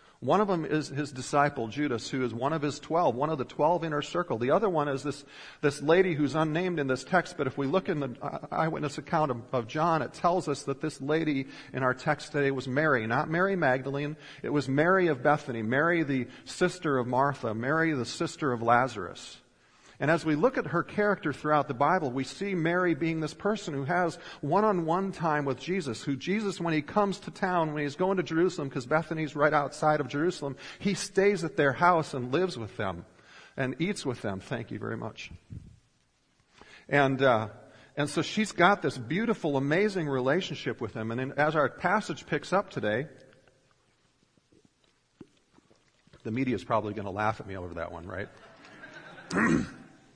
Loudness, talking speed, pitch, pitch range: -29 LUFS, 195 wpm, 150 Hz, 130-170 Hz